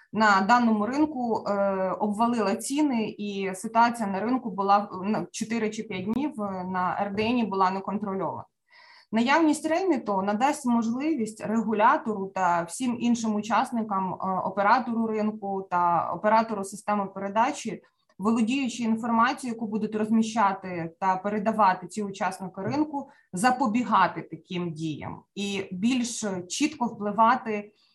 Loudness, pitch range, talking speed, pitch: -26 LUFS, 195-235 Hz, 115 wpm, 215 Hz